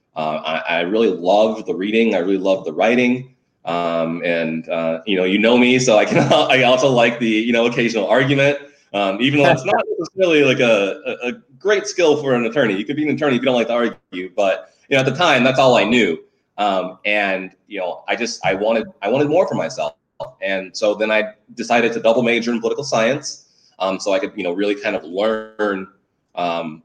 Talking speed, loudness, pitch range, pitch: 230 wpm, -17 LUFS, 95-130 Hz, 115 Hz